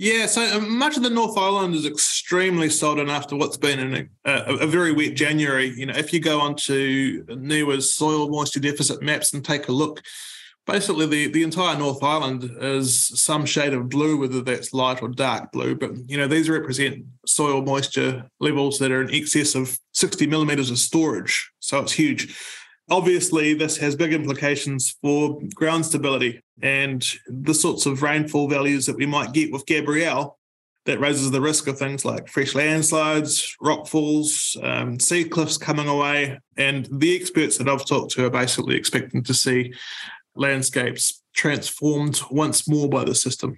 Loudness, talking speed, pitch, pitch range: -21 LUFS, 175 wpm, 145 Hz, 135-155 Hz